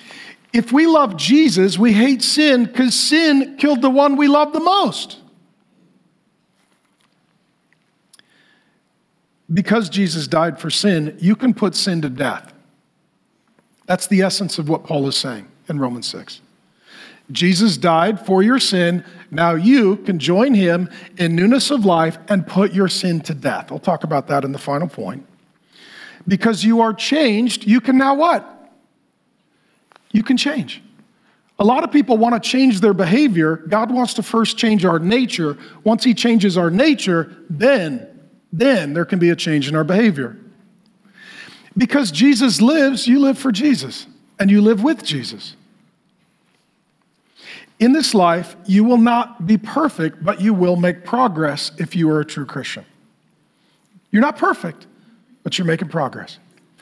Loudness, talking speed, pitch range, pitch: -16 LUFS, 155 wpm, 170-250 Hz, 210 Hz